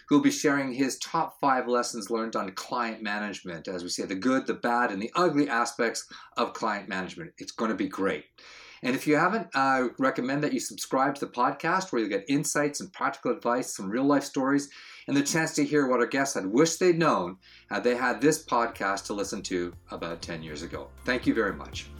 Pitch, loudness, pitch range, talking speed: 130 Hz, -28 LUFS, 105-145 Hz, 220 wpm